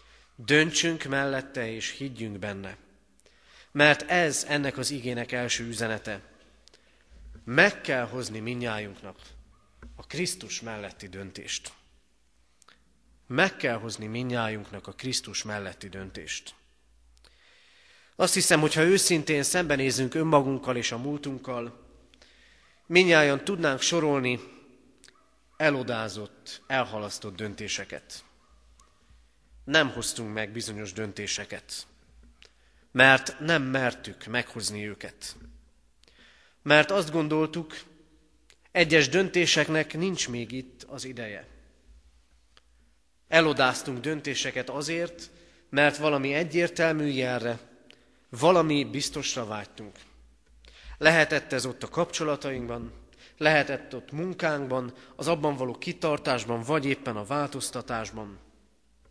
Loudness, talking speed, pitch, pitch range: -26 LUFS, 90 wpm, 125 Hz, 105-150 Hz